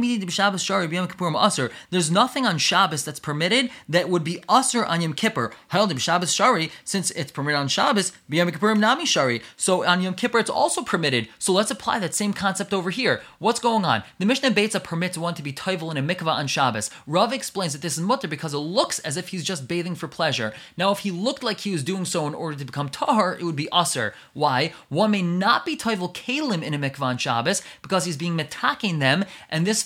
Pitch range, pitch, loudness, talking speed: 160-200 Hz, 180 Hz, -23 LUFS, 210 wpm